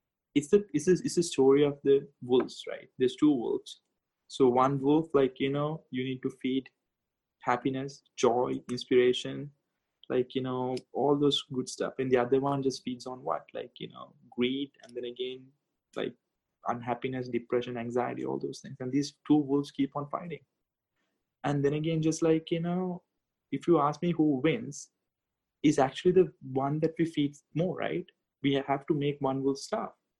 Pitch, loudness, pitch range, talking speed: 140 Hz, -30 LUFS, 130-155 Hz, 185 wpm